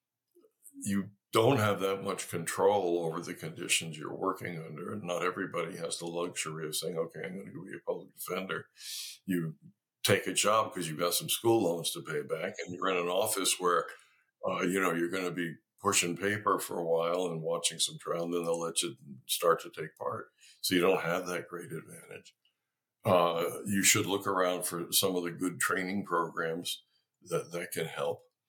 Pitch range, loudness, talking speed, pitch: 85-105 Hz, -32 LUFS, 200 wpm, 90 Hz